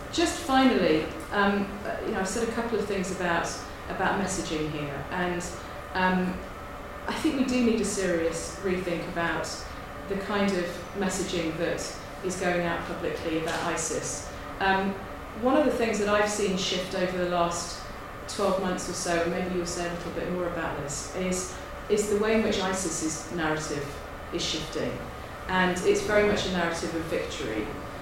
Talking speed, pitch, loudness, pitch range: 175 wpm, 185 Hz, -28 LUFS, 170-200 Hz